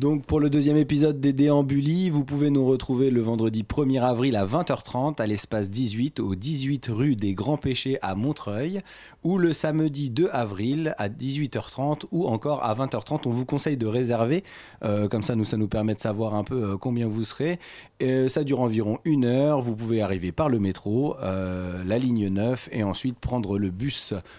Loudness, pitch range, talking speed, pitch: -25 LUFS, 110-145 Hz, 195 wpm, 125 Hz